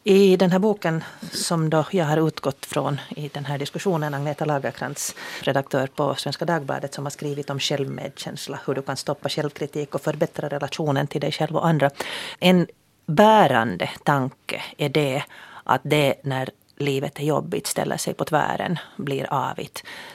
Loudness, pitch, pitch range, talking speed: -23 LUFS, 150 Hz, 140-165 Hz, 165 wpm